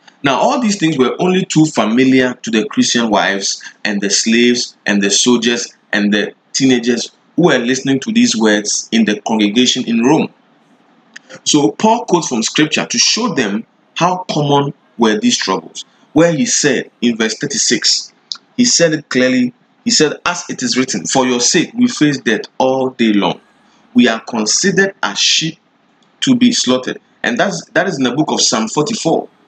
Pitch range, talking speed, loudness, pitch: 120-185 Hz, 180 wpm, -13 LUFS, 130 Hz